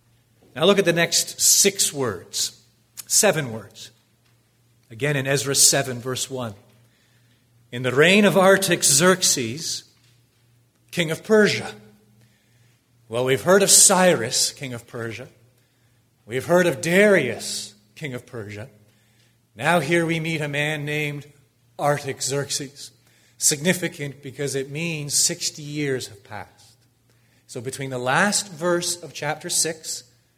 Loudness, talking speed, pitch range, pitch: -20 LUFS, 120 wpm, 120-160 Hz, 130 Hz